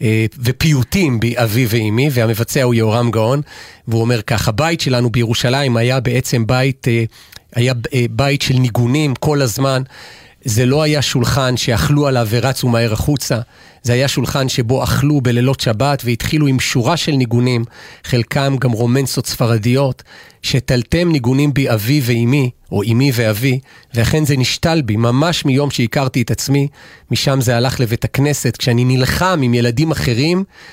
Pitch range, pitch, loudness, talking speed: 120-140 Hz, 125 Hz, -15 LUFS, 145 wpm